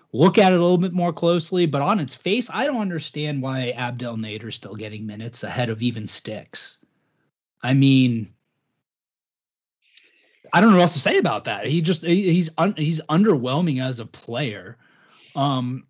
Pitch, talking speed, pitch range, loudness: 140 Hz, 175 wpm, 120-175 Hz, -21 LUFS